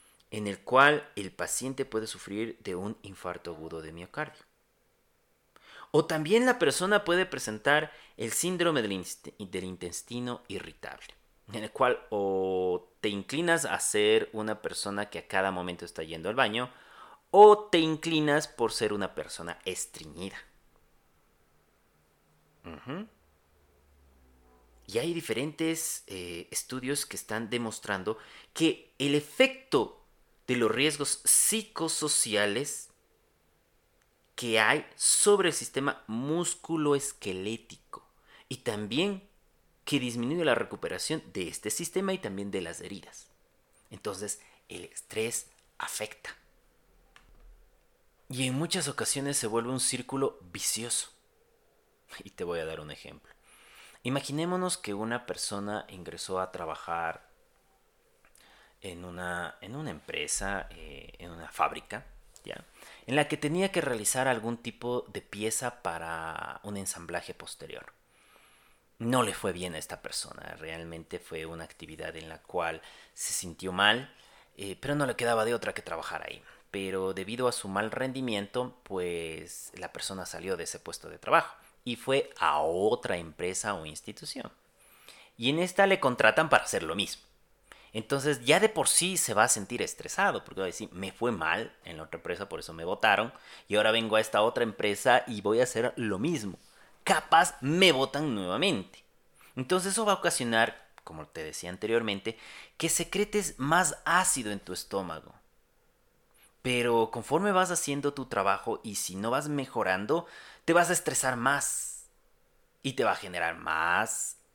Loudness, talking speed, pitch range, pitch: -29 LUFS, 145 wpm, 95-155 Hz, 120 Hz